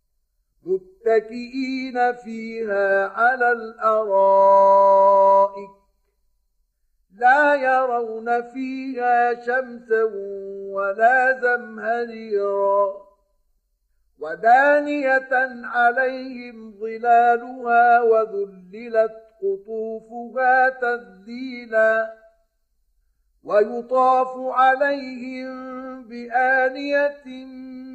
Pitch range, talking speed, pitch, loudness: 220-260 Hz, 40 wpm, 240 Hz, -19 LUFS